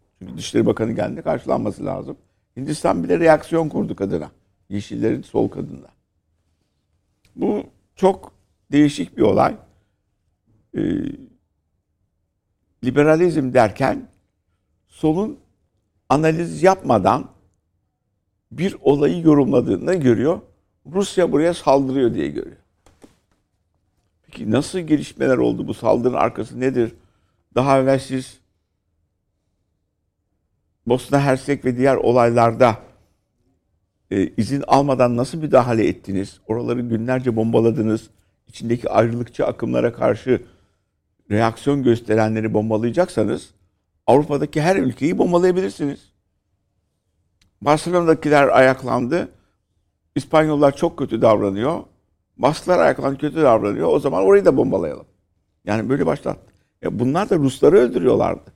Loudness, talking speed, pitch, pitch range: -19 LUFS, 95 wpm, 110 Hz, 95-135 Hz